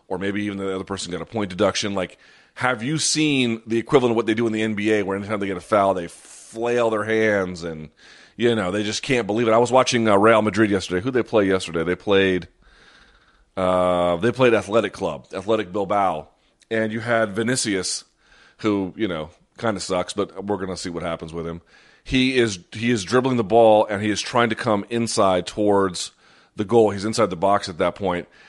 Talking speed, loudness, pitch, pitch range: 220 wpm, -21 LUFS, 105 Hz, 95-115 Hz